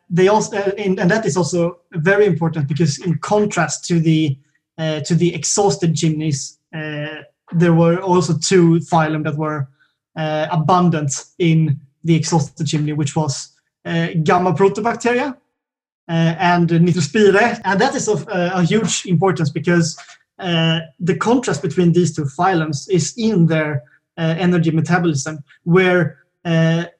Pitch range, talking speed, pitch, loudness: 155-185 Hz, 145 wpm, 170 Hz, -17 LUFS